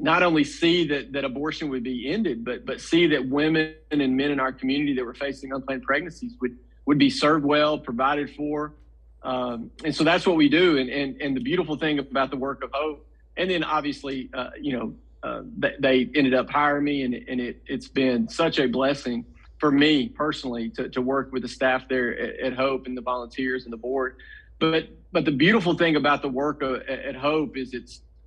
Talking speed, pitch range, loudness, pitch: 215 wpm, 130-150 Hz, -24 LUFS, 135 Hz